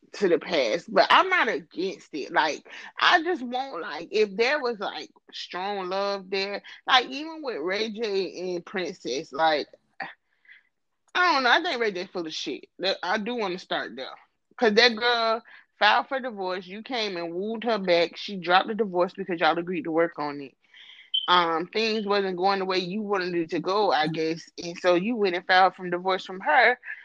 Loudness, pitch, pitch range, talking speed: -25 LUFS, 200 Hz, 180-240 Hz, 200 wpm